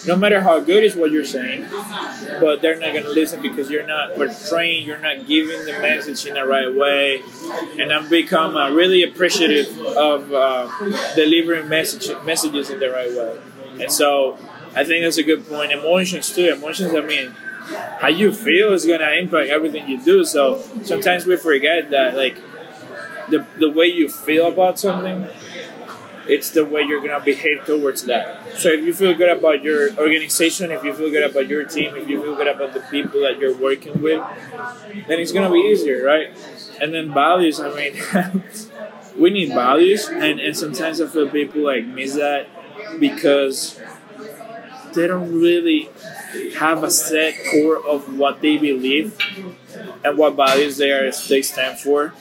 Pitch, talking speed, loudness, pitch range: 160 Hz, 175 wpm, -18 LUFS, 145-185 Hz